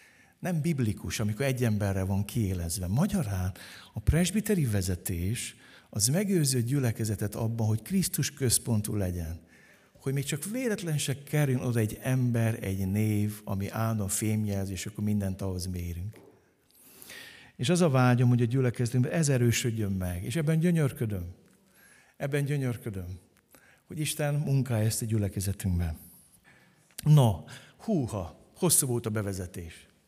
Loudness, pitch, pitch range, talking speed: -29 LUFS, 115 Hz, 100-140 Hz, 130 wpm